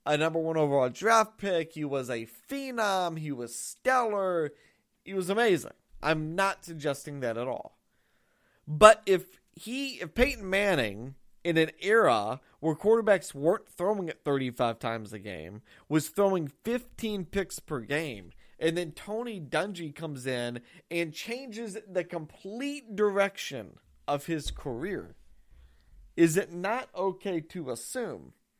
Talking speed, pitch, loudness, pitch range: 140 wpm, 170 Hz, -29 LUFS, 145-200 Hz